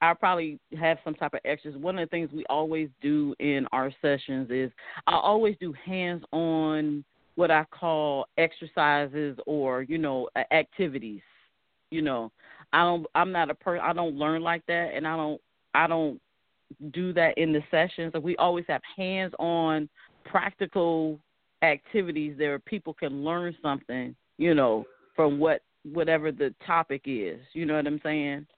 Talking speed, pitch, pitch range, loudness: 165 wpm, 160 Hz, 150-170 Hz, -28 LUFS